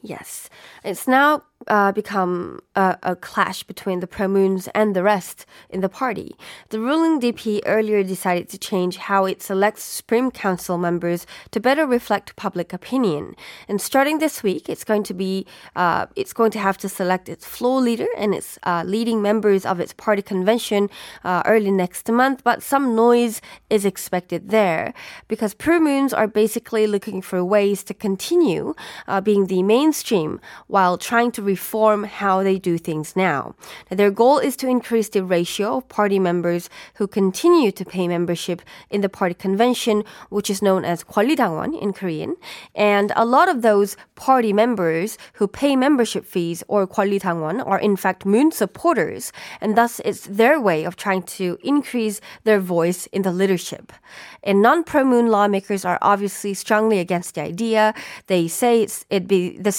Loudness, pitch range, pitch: -20 LUFS, 190-225 Hz, 205 Hz